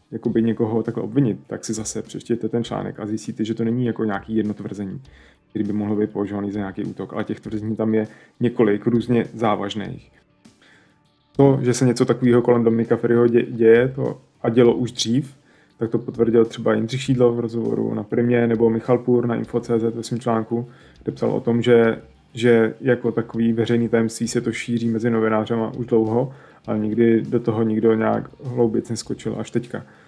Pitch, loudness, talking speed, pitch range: 115 Hz, -21 LUFS, 190 wpm, 110-120 Hz